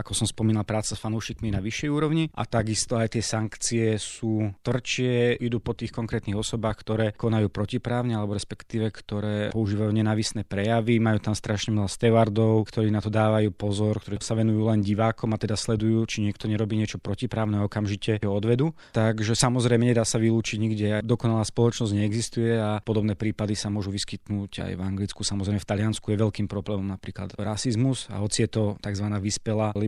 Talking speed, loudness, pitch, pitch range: 180 wpm, -26 LUFS, 110 Hz, 105-115 Hz